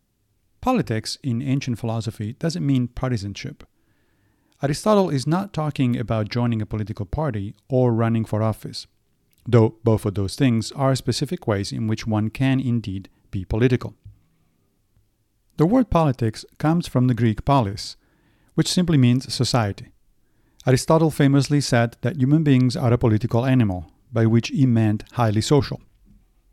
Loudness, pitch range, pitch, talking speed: -21 LUFS, 110-135 Hz, 120 Hz, 145 wpm